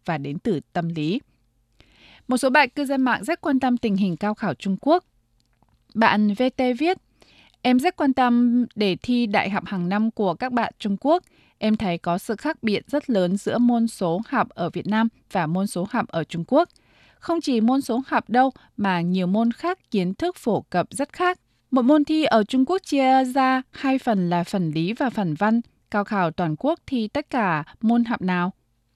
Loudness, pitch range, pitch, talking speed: -22 LUFS, 185-260 Hz, 225 Hz, 210 wpm